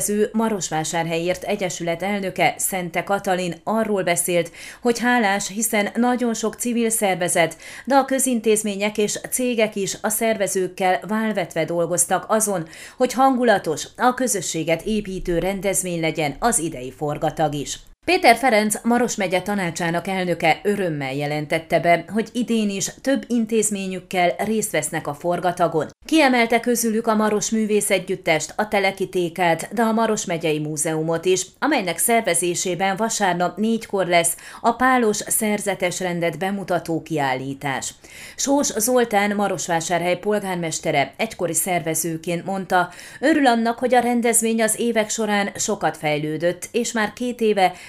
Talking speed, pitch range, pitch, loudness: 125 wpm, 170-220 Hz, 195 Hz, -21 LUFS